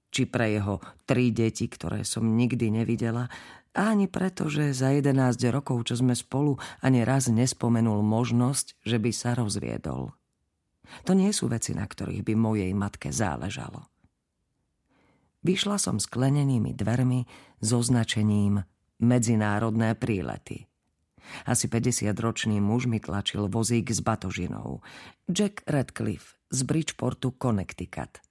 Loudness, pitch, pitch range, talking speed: -27 LUFS, 120 Hz, 110-130 Hz, 125 wpm